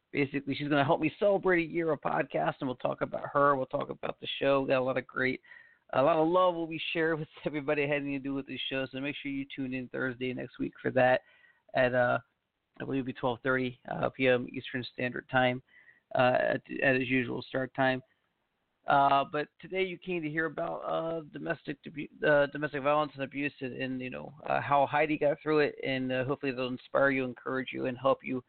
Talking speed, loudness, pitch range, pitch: 230 wpm, -31 LUFS, 130-150 Hz, 140 Hz